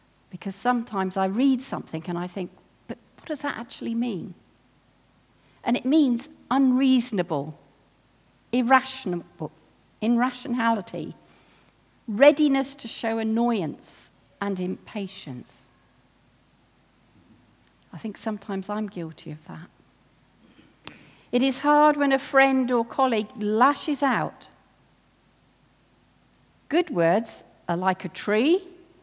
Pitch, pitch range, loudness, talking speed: 220 Hz, 175-265 Hz, -24 LUFS, 100 wpm